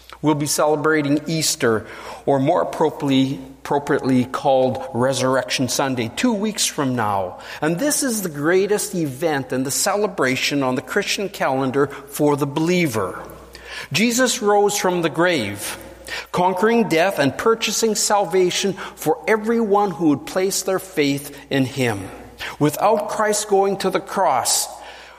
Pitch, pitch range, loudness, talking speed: 160 Hz, 140-205 Hz, -19 LUFS, 130 wpm